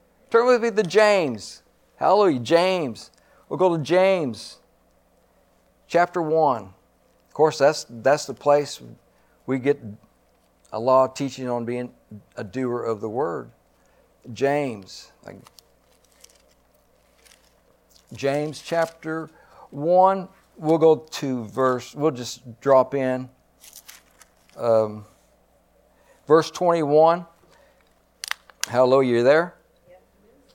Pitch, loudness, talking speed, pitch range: 140 Hz, -22 LUFS, 100 wpm, 125-170 Hz